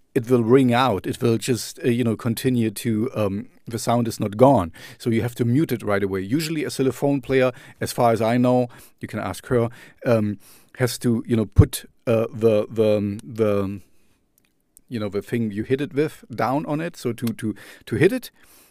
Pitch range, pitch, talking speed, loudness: 110-130 Hz, 115 Hz, 210 wpm, -22 LUFS